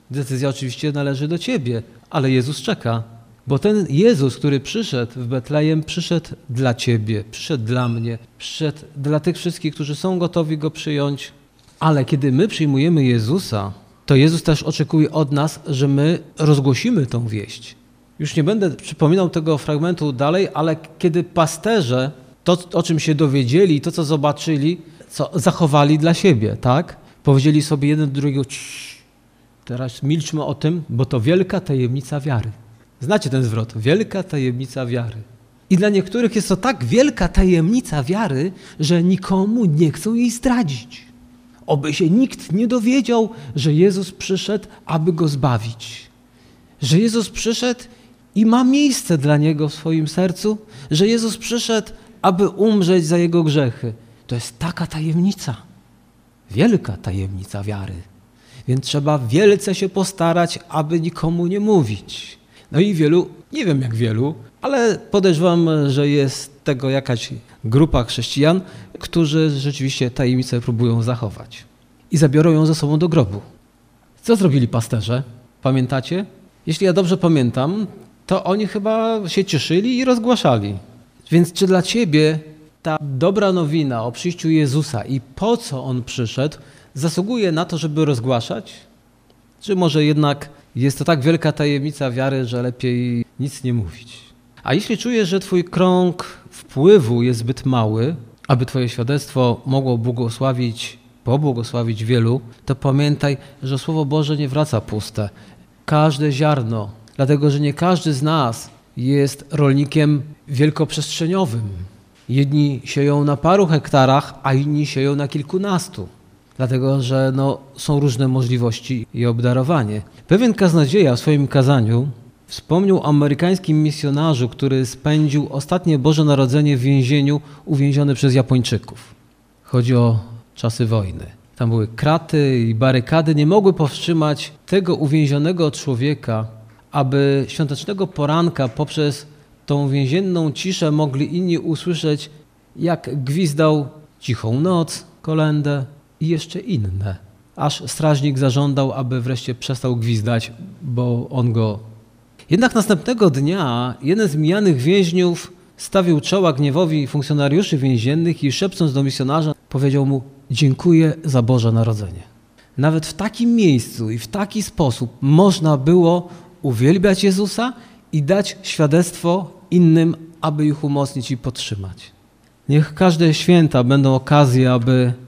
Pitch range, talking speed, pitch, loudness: 130-170 Hz, 135 wpm, 150 Hz, -18 LUFS